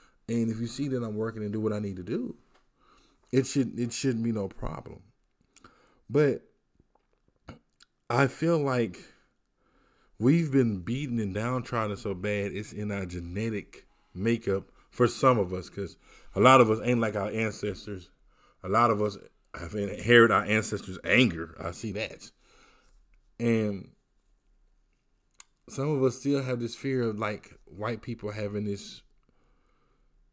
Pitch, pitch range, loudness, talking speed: 110 Hz, 100-120 Hz, -28 LUFS, 150 wpm